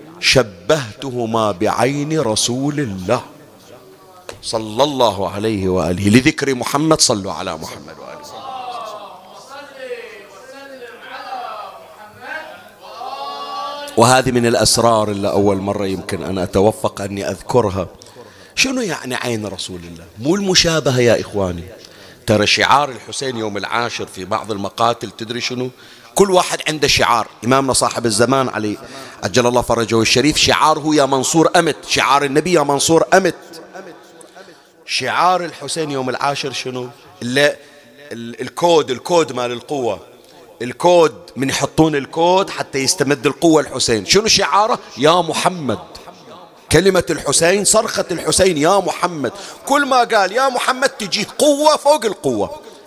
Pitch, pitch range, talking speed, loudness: 140 Hz, 115-175 Hz, 115 wpm, -16 LUFS